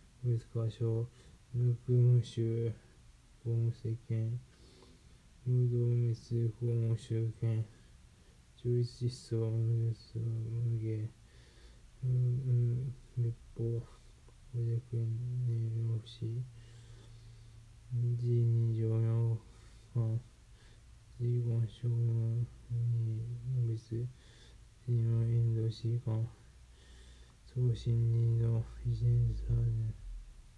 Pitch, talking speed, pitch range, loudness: 115 Hz, 100 characters per minute, 115-120 Hz, -35 LUFS